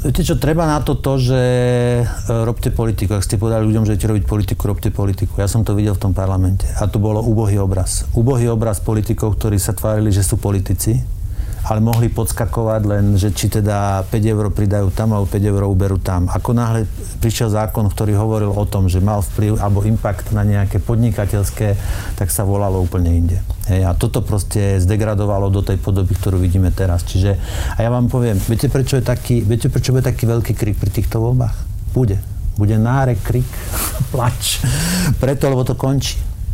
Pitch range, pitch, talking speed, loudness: 100-115 Hz, 105 Hz, 195 wpm, -17 LUFS